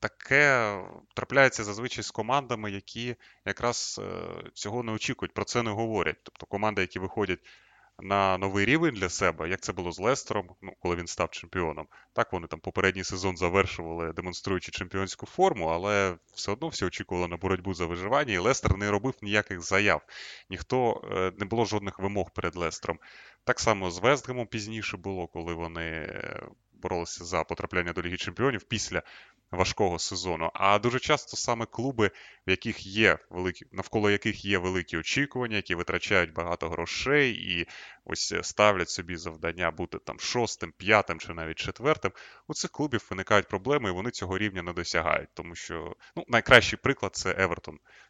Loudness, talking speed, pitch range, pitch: -28 LUFS, 165 wpm, 90-110 Hz, 100 Hz